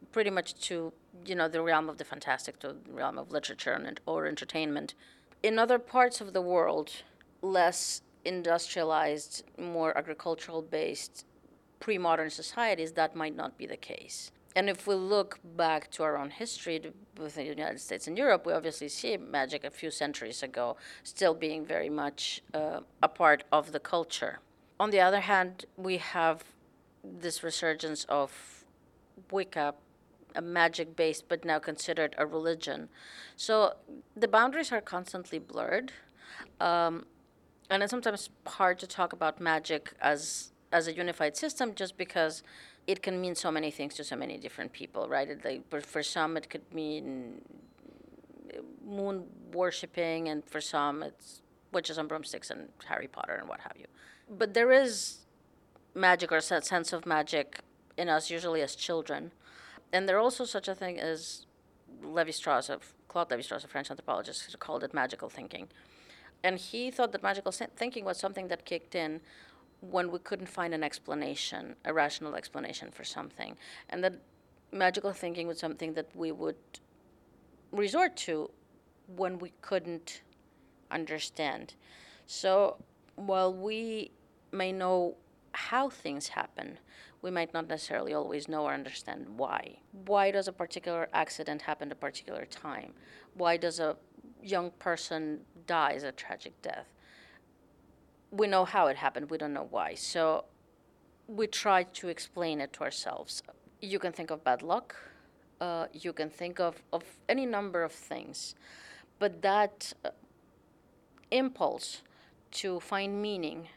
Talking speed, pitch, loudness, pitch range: 155 wpm, 170 Hz, -33 LUFS, 155-190 Hz